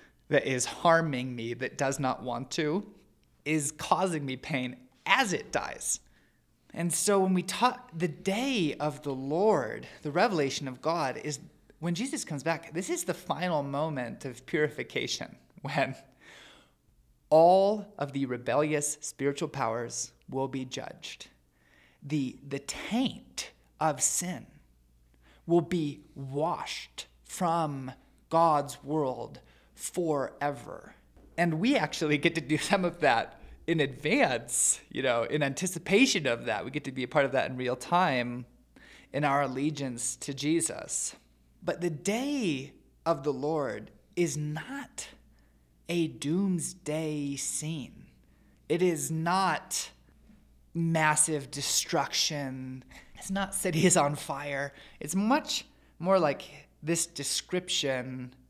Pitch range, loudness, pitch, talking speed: 135-175 Hz, -30 LUFS, 150 Hz, 125 wpm